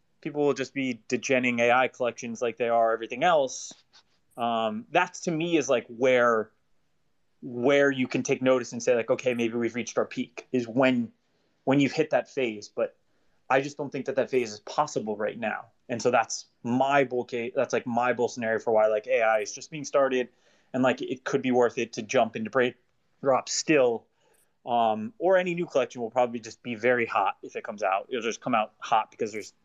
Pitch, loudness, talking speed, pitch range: 125 Hz, -27 LUFS, 215 wpm, 120-140 Hz